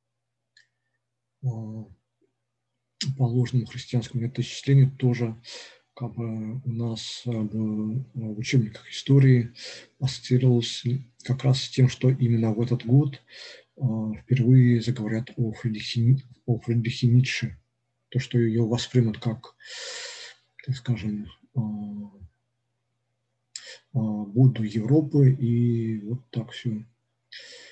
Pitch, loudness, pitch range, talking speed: 120 Hz, -25 LUFS, 115-130 Hz, 95 wpm